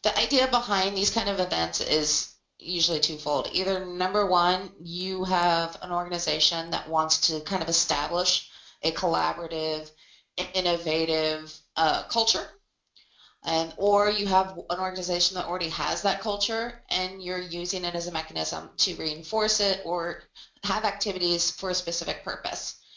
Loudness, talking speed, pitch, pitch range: -26 LUFS, 145 wpm, 175 Hz, 160-190 Hz